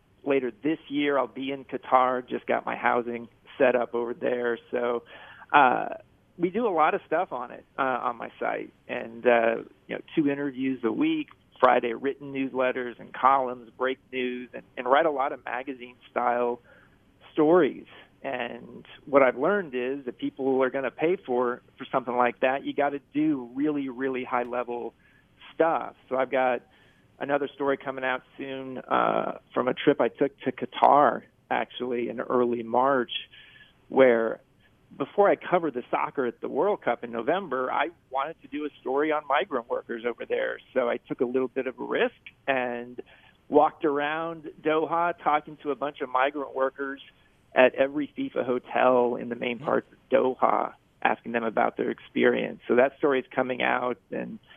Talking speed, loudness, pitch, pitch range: 180 wpm, -27 LUFS, 130 Hz, 125-140 Hz